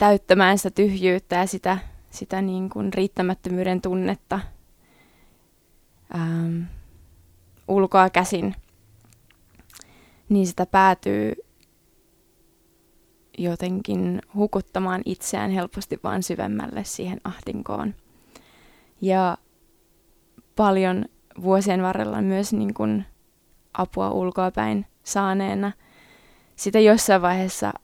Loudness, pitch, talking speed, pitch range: -23 LUFS, 185 Hz, 80 wpm, 165-195 Hz